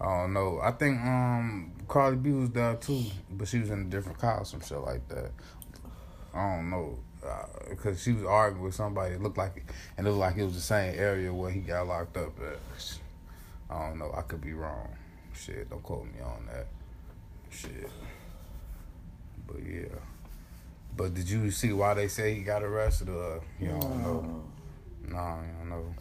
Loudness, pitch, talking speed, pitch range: -32 LUFS, 90 Hz, 200 wpm, 80-105 Hz